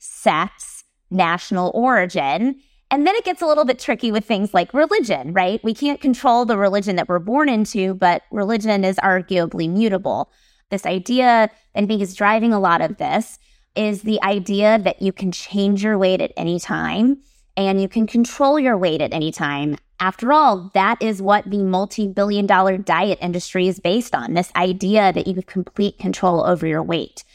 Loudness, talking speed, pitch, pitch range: -18 LUFS, 185 wpm, 200 Hz, 185-230 Hz